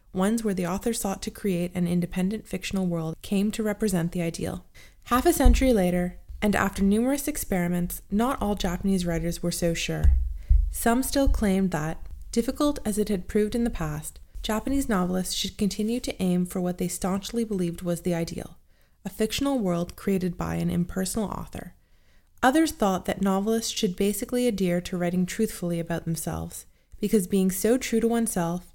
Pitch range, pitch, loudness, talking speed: 175-220 Hz, 195 Hz, -26 LUFS, 175 wpm